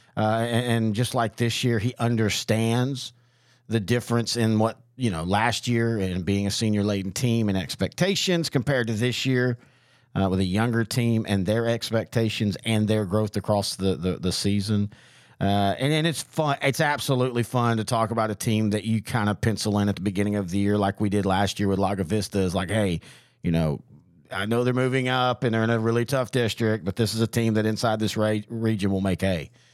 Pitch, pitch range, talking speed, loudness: 110 Hz, 100-120 Hz, 220 wpm, -24 LUFS